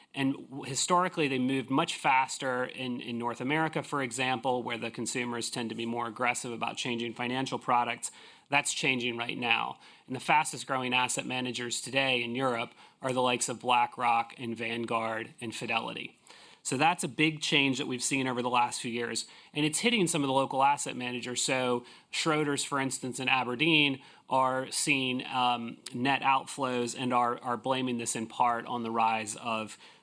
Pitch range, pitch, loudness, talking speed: 120-135 Hz, 125 Hz, -30 LUFS, 180 wpm